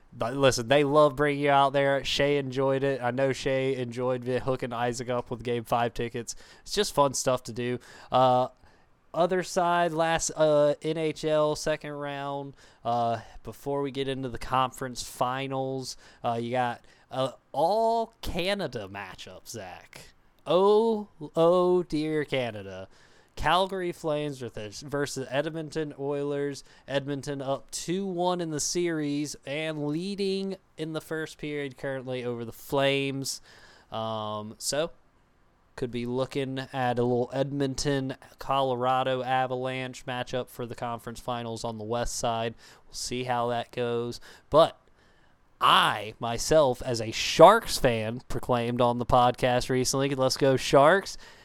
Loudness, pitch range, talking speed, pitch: -27 LUFS, 120-150 Hz, 140 wpm, 130 Hz